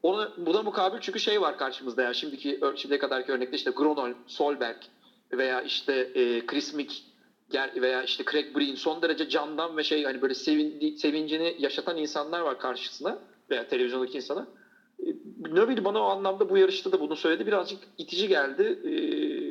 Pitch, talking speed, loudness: 160 Hz, 160 wpm, -28 LUFS